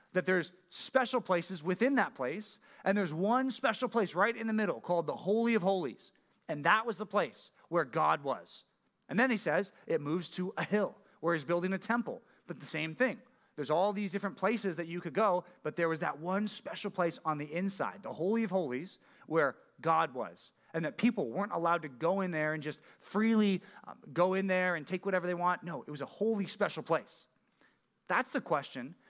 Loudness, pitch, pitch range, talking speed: -33 LUFS, 190 Hz, 170-215 Hz, 210 wpm